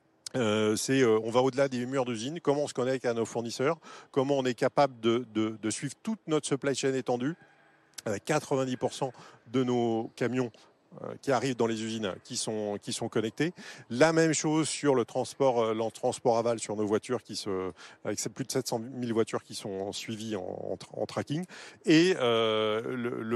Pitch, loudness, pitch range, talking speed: 125 Hz, -30 LUFS, 110-135 Hz, 200 wpm